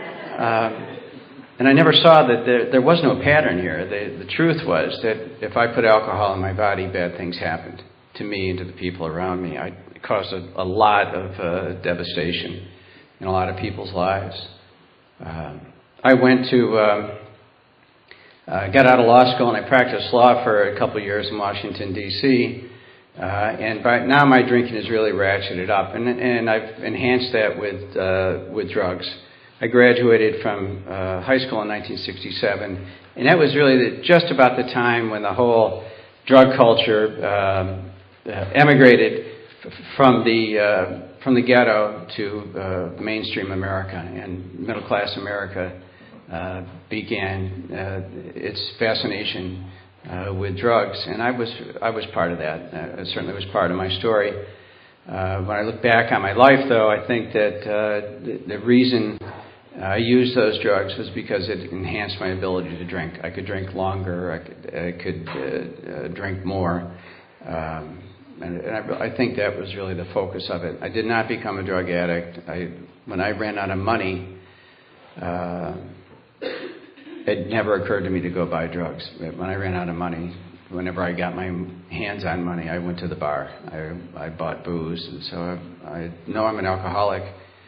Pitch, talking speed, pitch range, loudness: 95 Hz, 180 wpm, 90-115 Hz, -20 LUFS